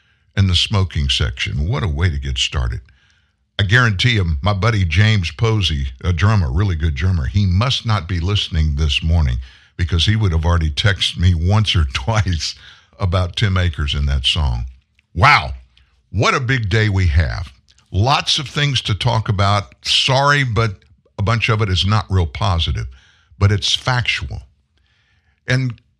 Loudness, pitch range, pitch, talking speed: -17 LUFS, 80-110 Hz, 95 Hz, 165 wpm